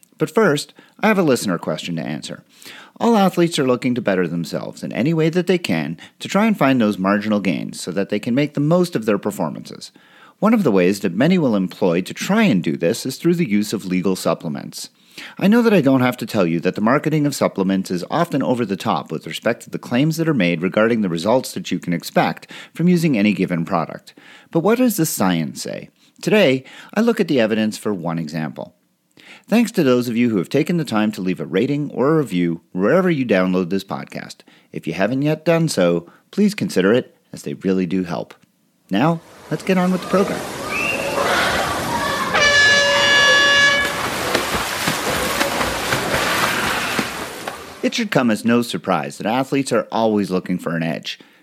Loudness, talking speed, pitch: -18 LUFS, 200 wpm, 135 Hz